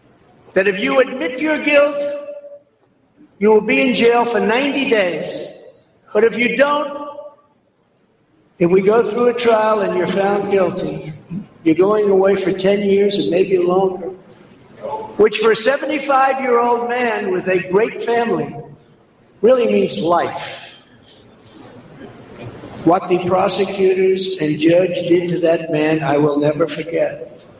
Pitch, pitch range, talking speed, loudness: 205 Hz, 185-265 Hz, 140 wpm, -16 LUFS